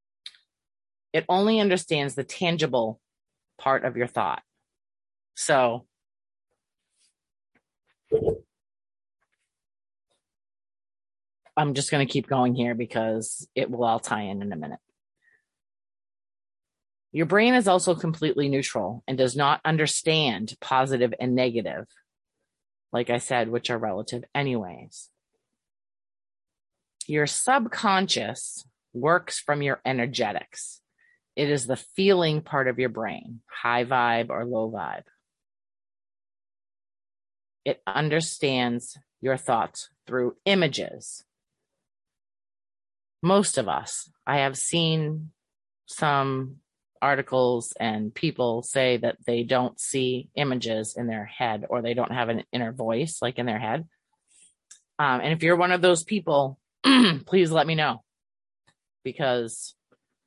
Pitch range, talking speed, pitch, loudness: 120-180 Hz, 115 wpm, 135 Hz, -25 LUFS